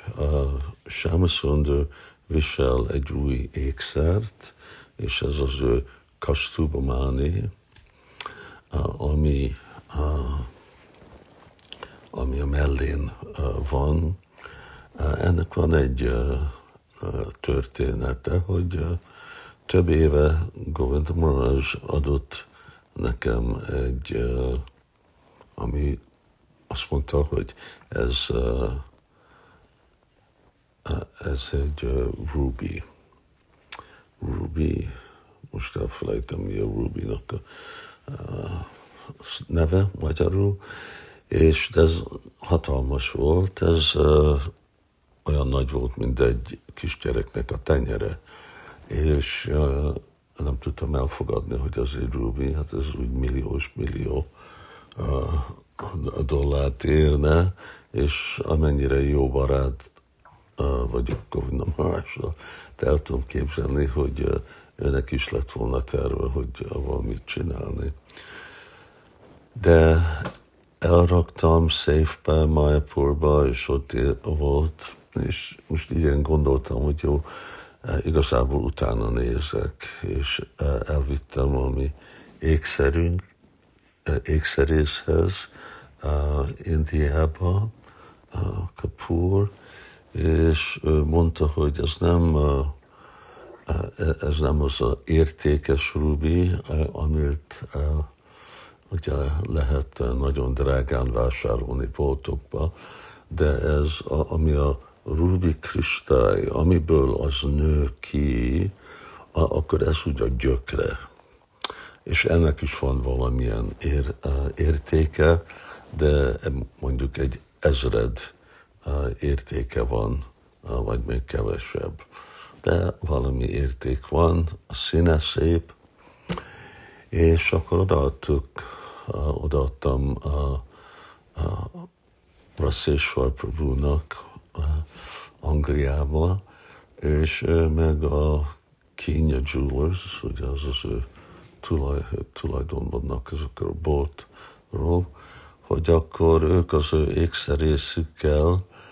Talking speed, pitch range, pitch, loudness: 90 wpm, 70-80 Hz, 75 Hz, -25 LUFS